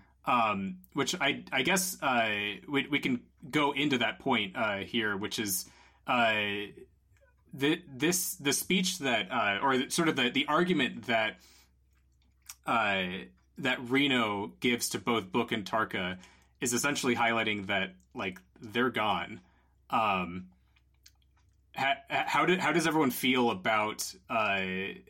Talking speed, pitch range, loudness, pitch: 140 wpm, 90-140 Hz, -30 LUFS, 115 Hz